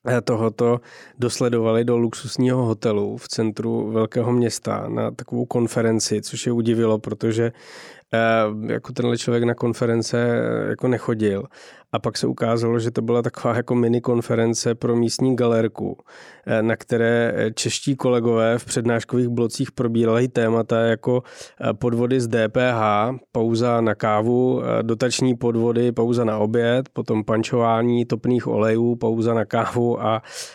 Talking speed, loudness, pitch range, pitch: 130 wpm, -21 LUFS, 115-120 Hz, 120 Hz